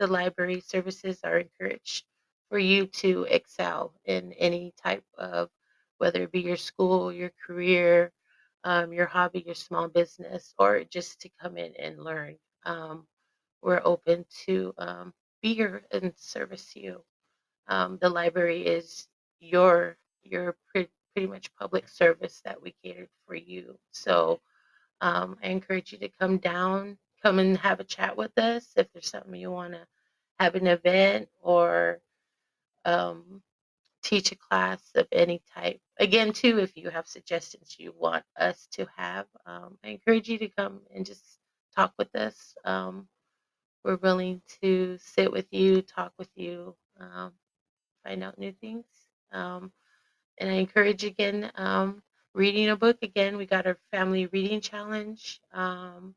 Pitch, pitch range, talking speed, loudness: 185 Hz, 170-195 Hz, 155 wpm, -27 LUFS